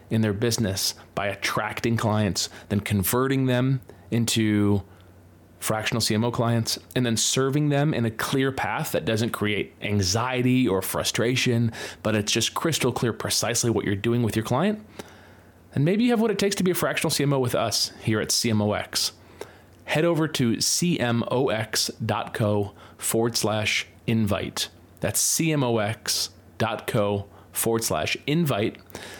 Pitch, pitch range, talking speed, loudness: 115 Hz, 105-130 Hz, 140 wpm, -24 LUFS